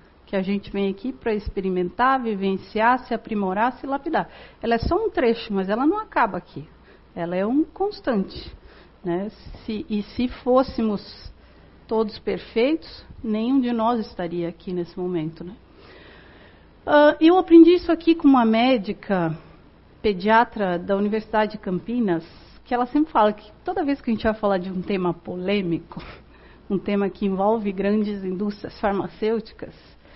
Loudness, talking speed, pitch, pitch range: -22 LUFS, 150 wpm, 215 Hz, 195-250 Hz